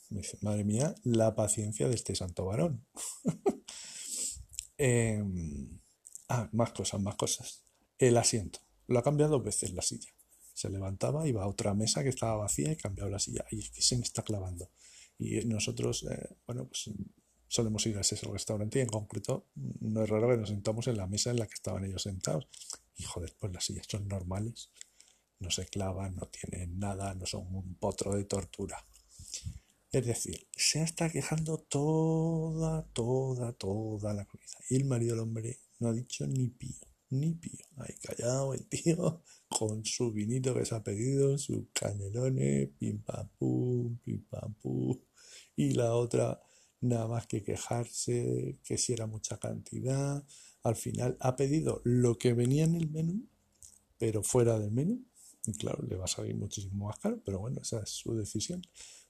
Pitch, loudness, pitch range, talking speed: 110 Hz, -34 LUFS, 100-125 Hz, 175 wpm